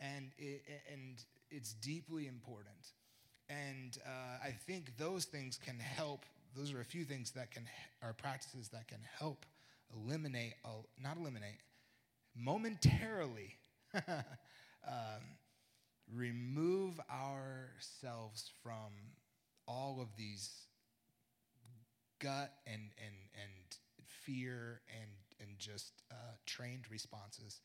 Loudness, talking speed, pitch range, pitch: -47 LUFS, 105 wpm, 115-140 Hz, 125 Hz